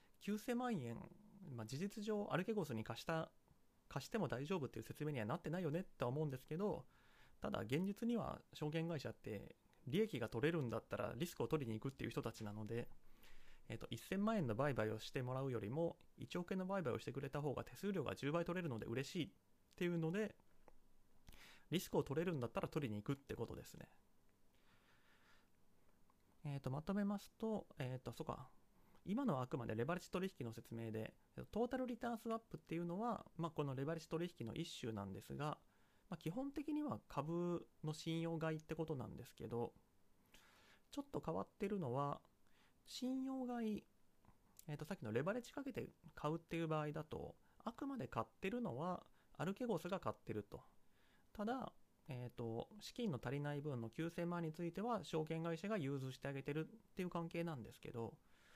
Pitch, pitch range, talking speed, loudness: 160 Hz, 125-195 Hz, 375 characters per minute, -46 LUFS